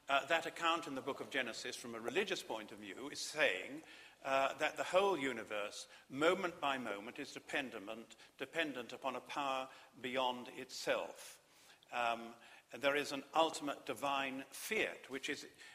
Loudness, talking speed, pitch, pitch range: -39 LUFS, 160 wpm, 135 Hz, 125-145 Hz